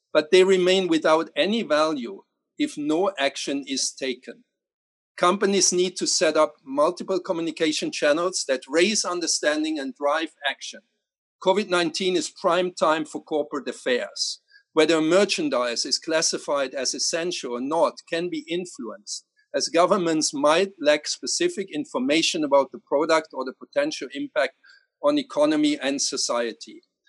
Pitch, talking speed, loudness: 180 Hz, 135 wpm, -23 LUFS